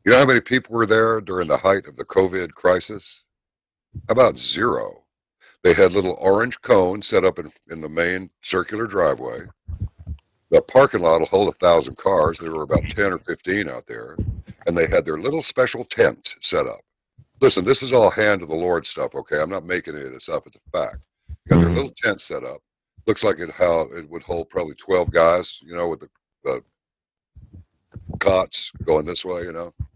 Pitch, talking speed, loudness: 115 Hz, 200 wpm, -20 LUFS